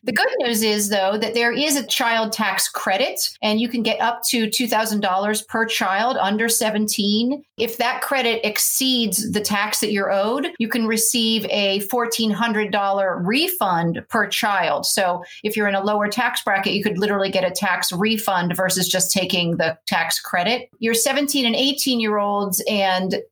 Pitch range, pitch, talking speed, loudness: 195-235 Hz, 215 Hz, 175 wpm, -19 LUFS